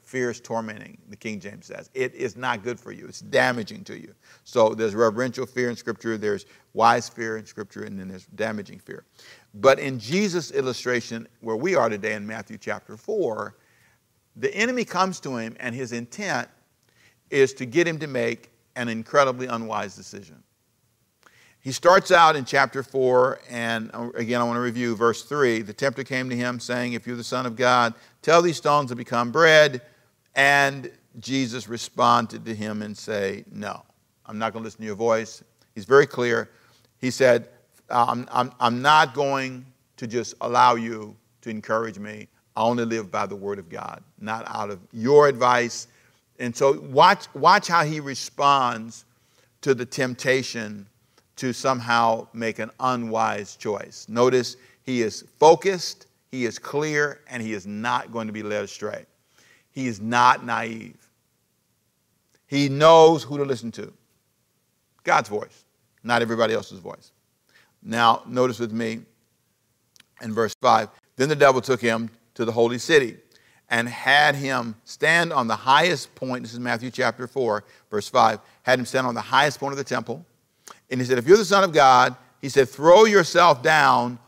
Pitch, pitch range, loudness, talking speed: 120 Hz, 115-135 Hz, -22 LUFS, 175 wpm